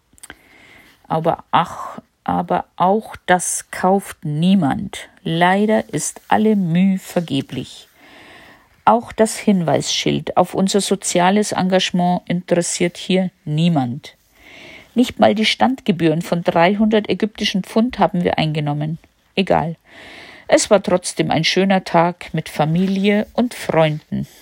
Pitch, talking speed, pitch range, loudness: 180 Hz, 110 wpm, 165-205 Hz, -18 LUFS